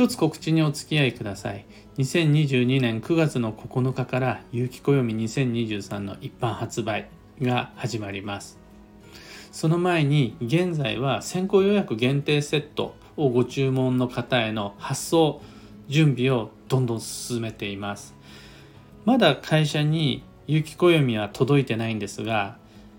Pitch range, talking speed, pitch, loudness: 110-150 Hz, 255 characters per minute, 125 Hz, -24 LUFS